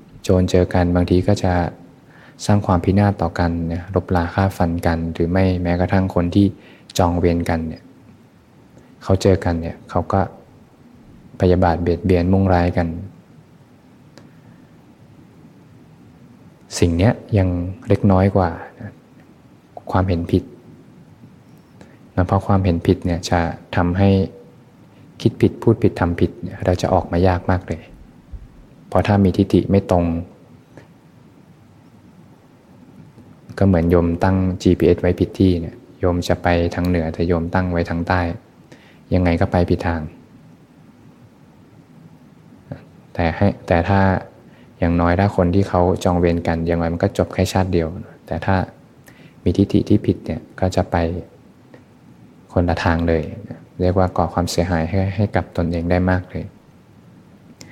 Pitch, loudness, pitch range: 90 Hz, -19 LUFS, 85-95 Hz